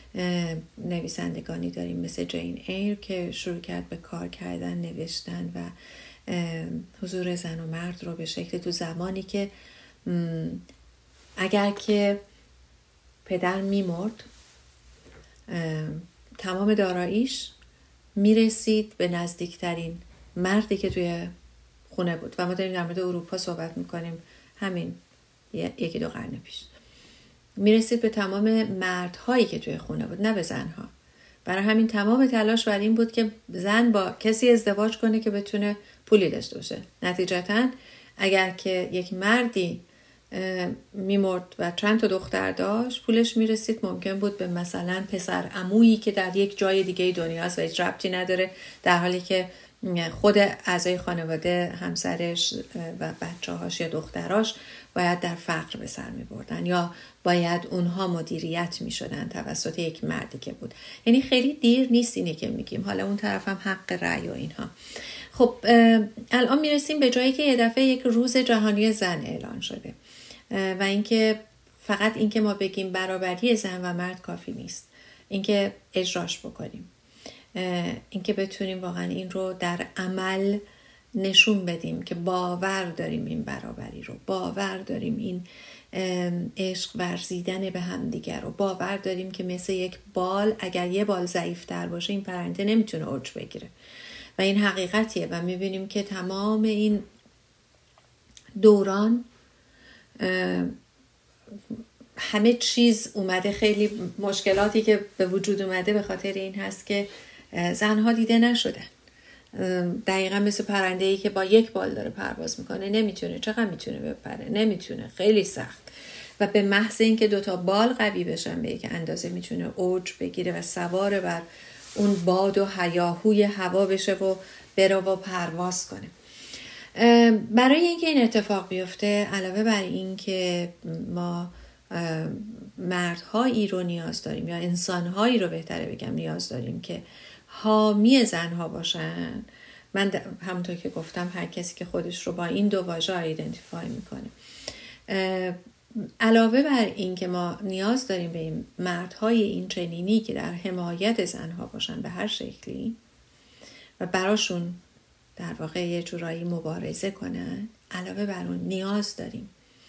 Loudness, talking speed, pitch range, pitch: -26 LUFS, 140 wpm, 175-215 Hz, 190 Hz